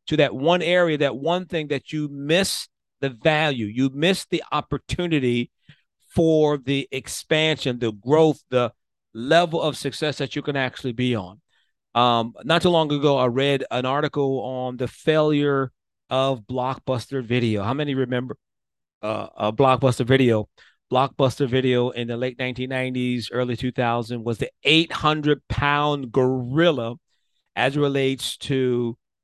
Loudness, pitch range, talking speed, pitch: -22 LUFS, 125-150 Hz, 140 wpm, 135 Hz